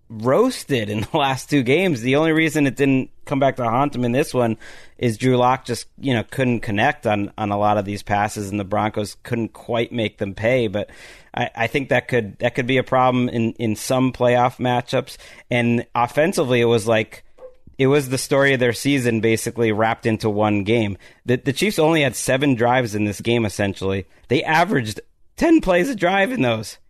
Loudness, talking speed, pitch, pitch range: -20 LUFS, 210 wpm, 120 Hz, 110-135 Hz